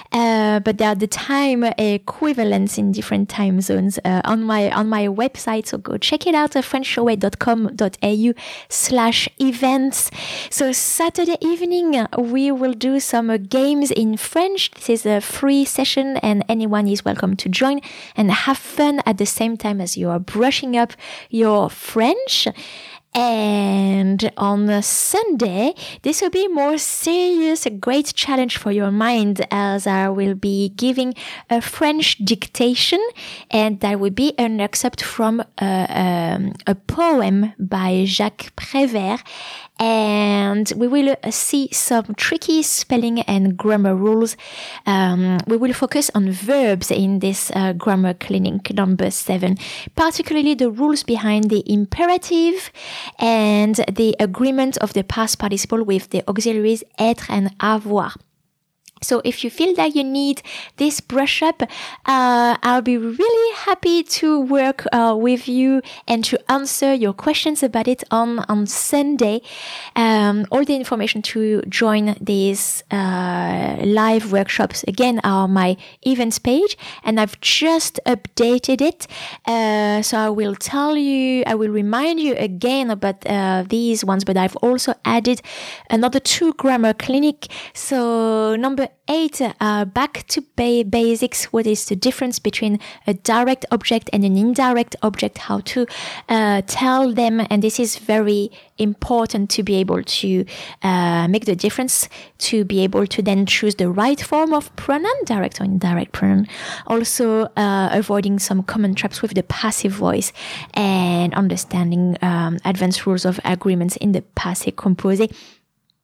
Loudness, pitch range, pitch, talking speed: -18 LUFS, 200-265 Hz, 225 Hz, 150 wpm